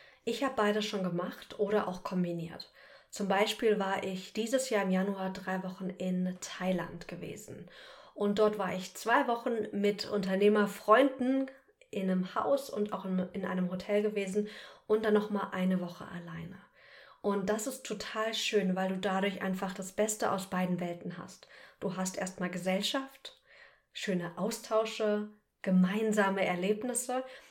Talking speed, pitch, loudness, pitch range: 145 wpm, 200 Hz, -32 LUFS, 185-215 Hz